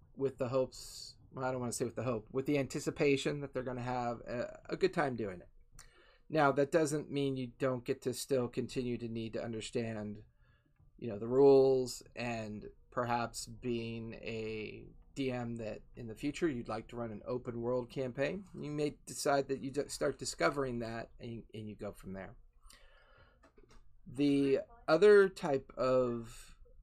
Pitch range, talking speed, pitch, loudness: 115-140 Hz, 170 wpm, 125 Hz, -35 LUFS